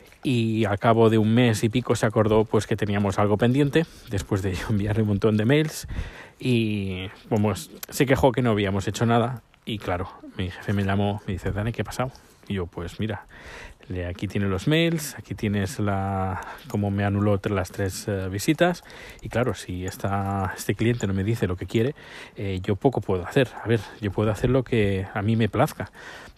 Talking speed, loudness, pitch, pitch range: 200 wpm, -25 LUFS, 105 Hz, 100-120 Hz